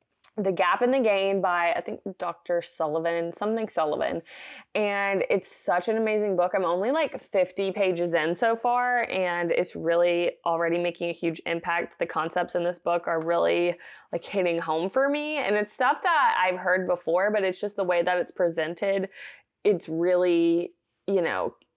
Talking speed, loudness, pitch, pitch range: 180 wpm, -26 LUFS, 180 Hz, 170-205 Hz